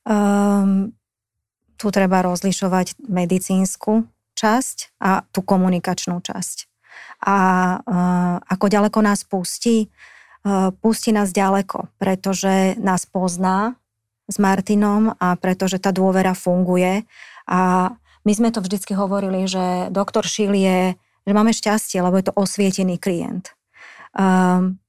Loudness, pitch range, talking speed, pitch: -19 LUFS, 185-205 Hz, 120 wpm, 190 Hz